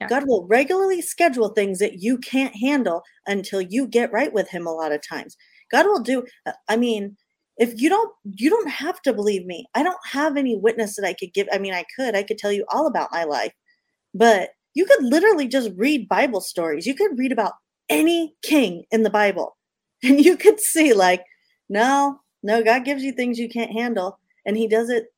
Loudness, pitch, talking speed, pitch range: -20 LUFS, 235 Hz, 210 wpm, 200-285 Hz